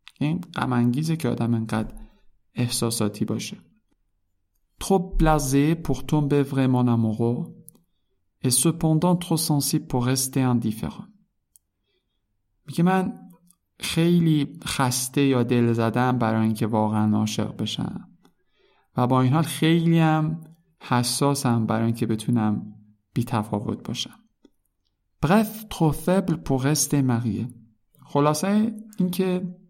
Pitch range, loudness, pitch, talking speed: 110-160 Hz, -23 LUFS, 130 Hz, 110 wpm